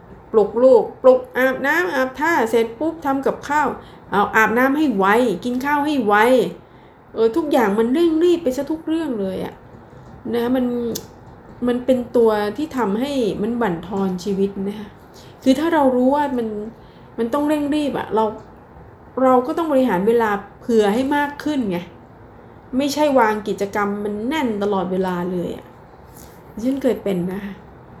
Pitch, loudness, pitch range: 245 Hz, -19 LUFS, 210-285 Hz